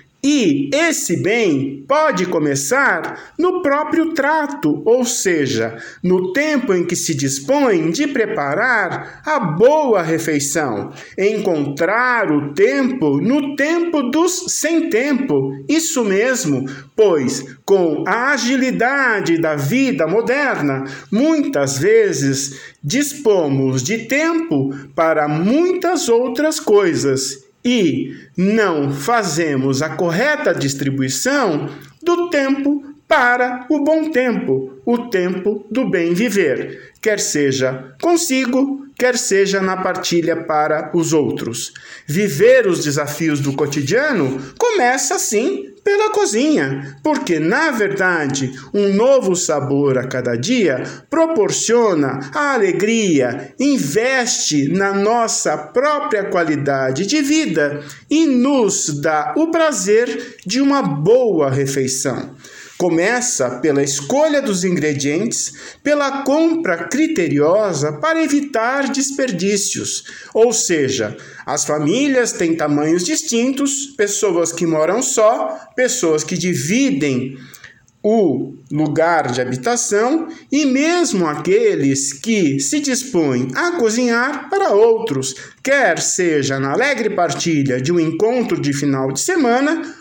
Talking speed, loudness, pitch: 105 wpm, -16 LUFS, 220 Hz